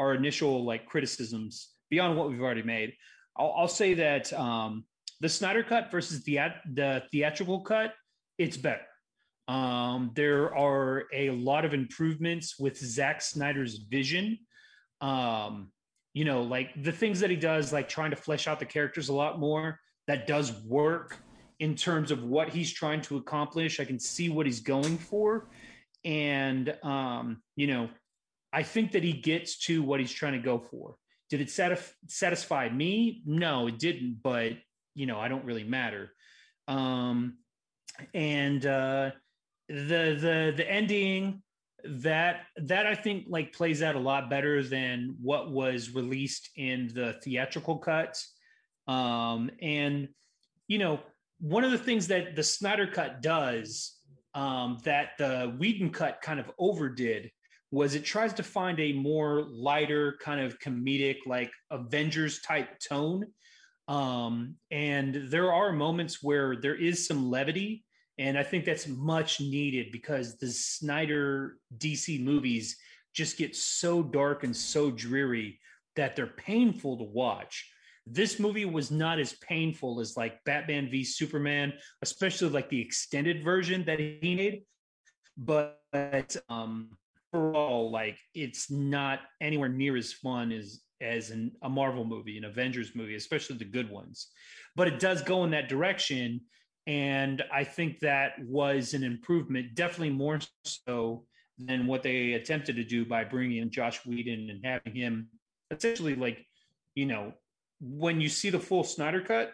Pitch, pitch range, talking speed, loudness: 145 Hz, 130-160 Hz, 155 wpm, -31 LUFS